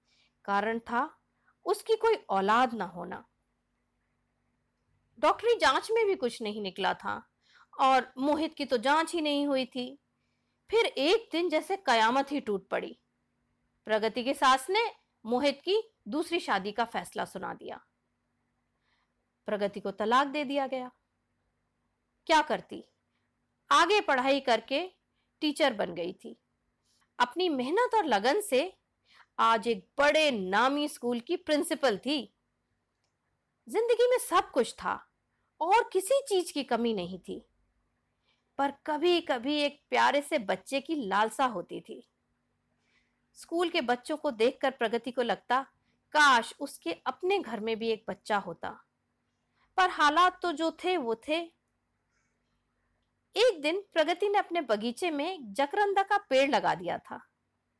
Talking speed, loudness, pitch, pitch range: 135 wpm, -29 LUFS, 280 Hz, 235-345 Hz